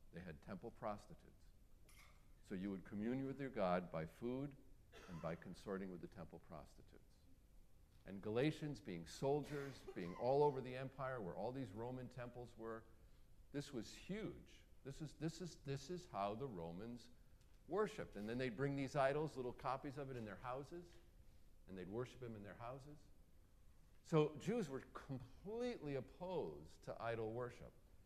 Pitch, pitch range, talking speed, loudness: 125 Hz, 100-140 Hz, 165 wpm, -47 LUFS